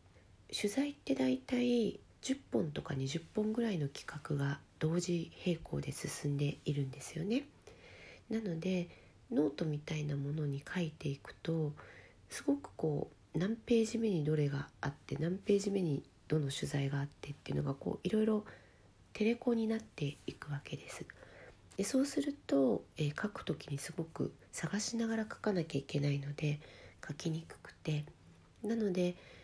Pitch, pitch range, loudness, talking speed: 155 Hz, 140-205 Hz, -37 LUFS, 300 characters per minute